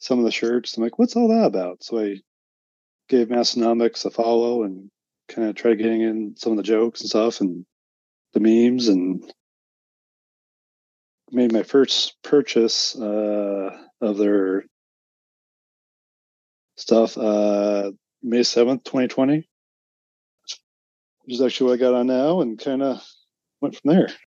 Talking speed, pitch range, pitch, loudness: 145 wpm, 100-120 Hz, 115 Hz, -21 LUFS